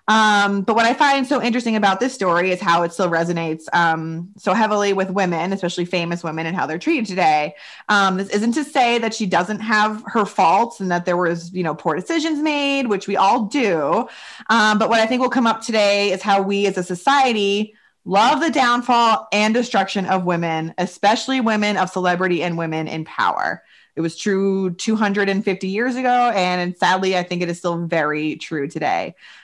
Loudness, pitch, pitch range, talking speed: -19 LUFS, 195 Hz, 175-225 Hz, 200 wpm